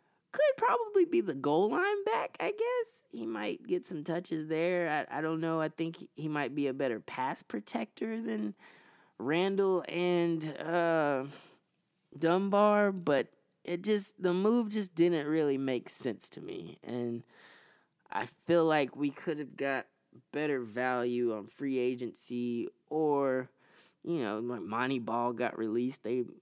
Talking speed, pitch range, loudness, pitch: 155 wpm, 125-180 Hz, -32 LUFS, 155 Hz